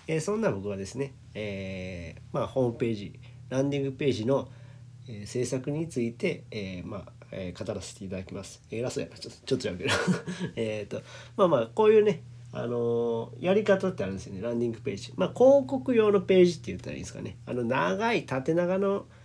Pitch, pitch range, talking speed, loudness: 125 Hz, 110-165 Hz, 395 characters per minute, -28 LUFS